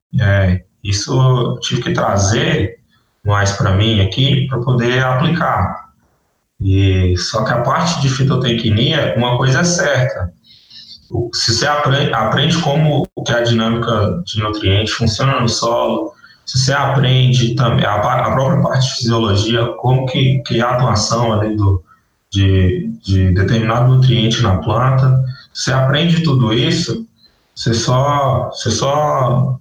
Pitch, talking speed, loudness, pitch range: 120 Hz, 140 wpm, -15 LUFS, 110-135 Hz